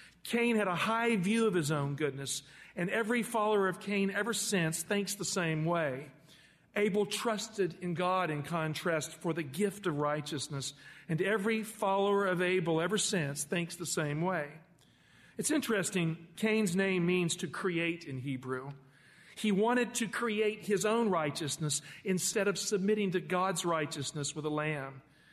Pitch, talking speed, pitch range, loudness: 180 Hz, 160 wpm, 155-205 Hz, -33 LUFS